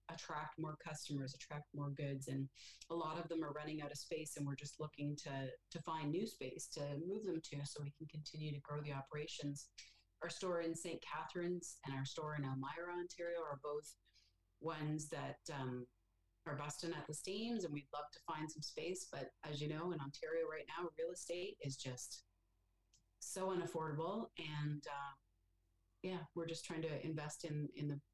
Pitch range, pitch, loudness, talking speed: 140-165 Hz, 150 Hz, -46 LUFS, 190 wpm